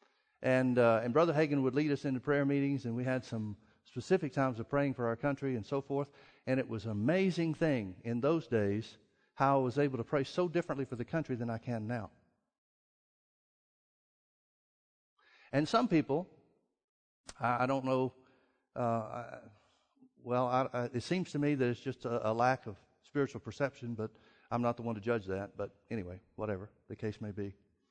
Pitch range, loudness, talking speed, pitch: 115-140 Hz, -34 LUFS, 190 wpm, 125 Hz